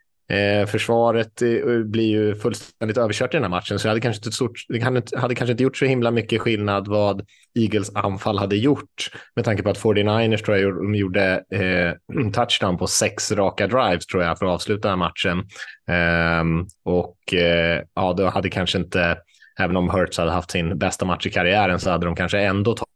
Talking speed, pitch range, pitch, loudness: 210 wpm, 90-115 Hz, 100 Hz, -21 LUFS